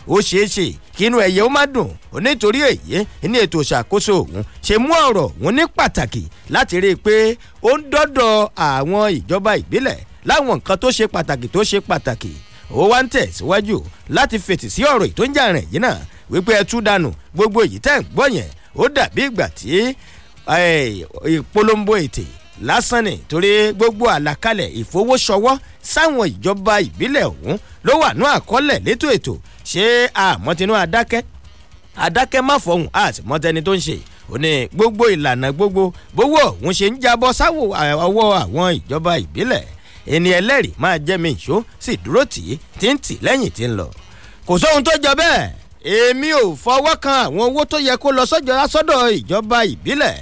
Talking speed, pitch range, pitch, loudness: 155 wpm, 160-245 Hz, 205 Hz, -16 LUFS